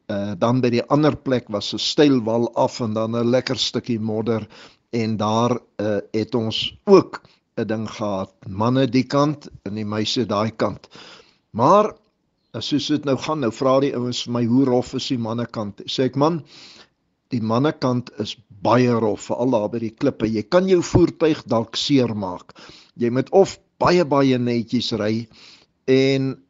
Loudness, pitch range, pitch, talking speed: -20 LUFS, 110-135 Hz, 120 Hz, 175 wpm